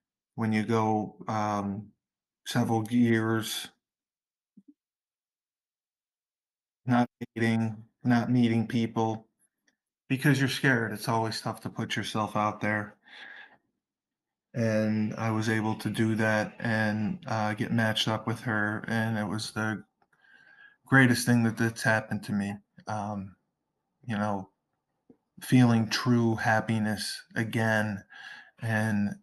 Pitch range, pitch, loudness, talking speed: 105-115 Hz, 110 Hz, -28 LUFS, 110 wpm